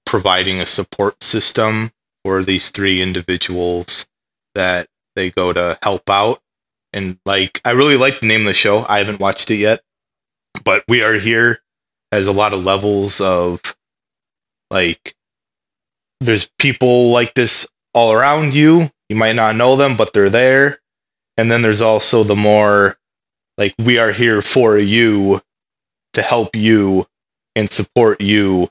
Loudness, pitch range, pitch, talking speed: -13 LUFS, 95-115 Hz, 105 Hz, 155 wpm